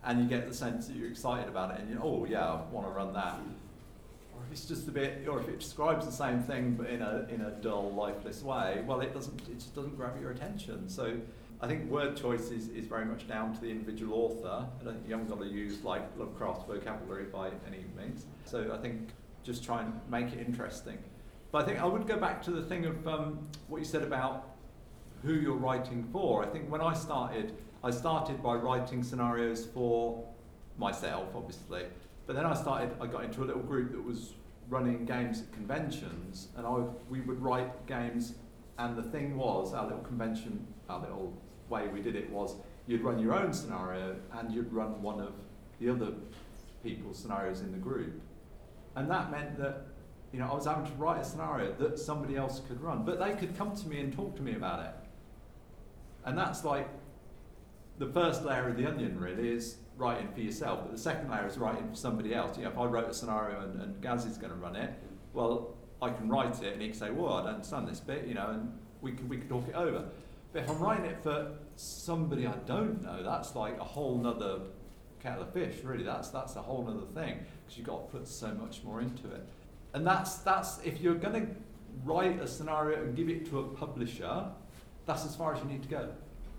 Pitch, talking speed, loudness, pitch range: 120 Hz, 225 wpm, -36 LUFS, 115-150 Hz